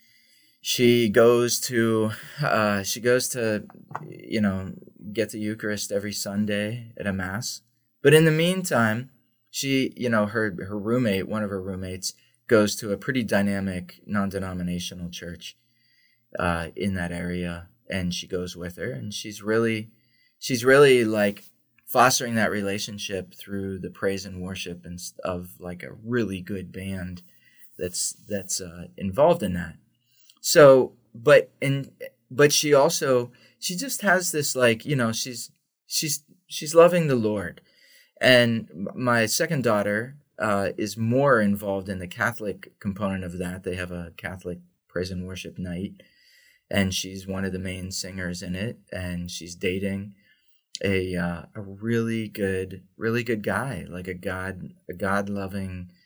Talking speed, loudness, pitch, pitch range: 150 wpm, -24 LUFS, 100 Hz, 95-120 Hz